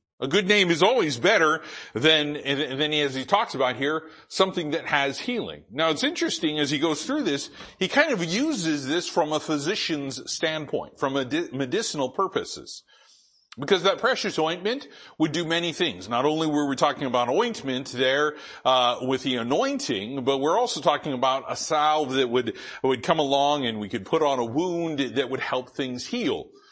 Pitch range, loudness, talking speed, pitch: 135-190 Hz, -24 LUFS, 190 wpm, 155 Hz